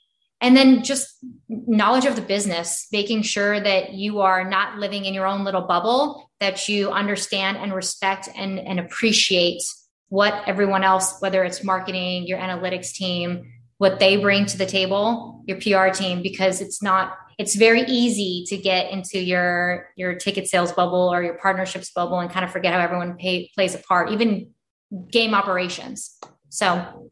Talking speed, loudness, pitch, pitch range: 170 wpm, -21 LUFS, 190 Hz, 185-205 Hz